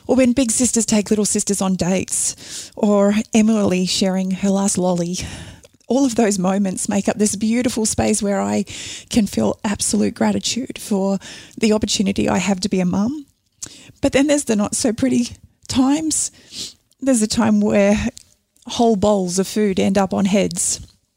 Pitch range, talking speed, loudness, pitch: 190-230 Hz, 165 wpm, -18 LUFS, 210 Hz